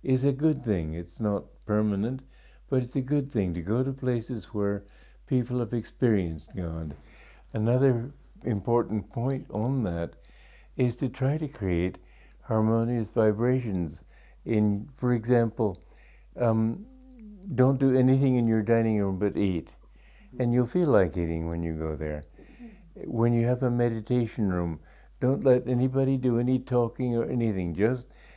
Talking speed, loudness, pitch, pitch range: 150 wpm, -27 LUFS, 115 Hz, 100-130 Hz